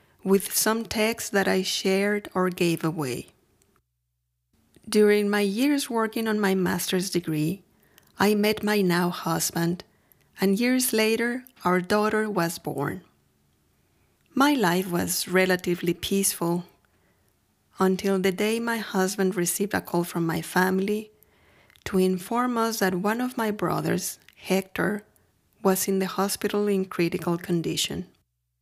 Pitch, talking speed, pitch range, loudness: 190 Hz, 130 wpm, 175-210 Hz, -25 LUFS